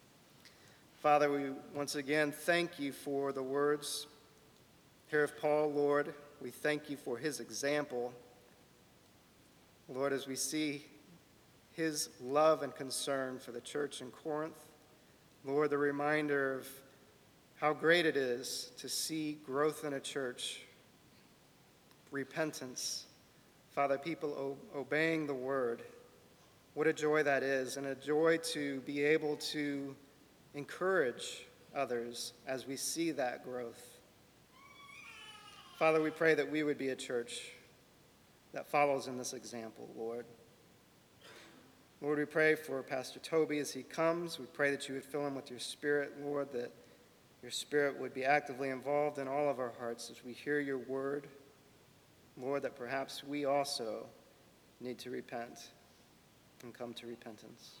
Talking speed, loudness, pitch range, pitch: 140 wpm, -36 LUFS, 130-150 Hz, 140 Hz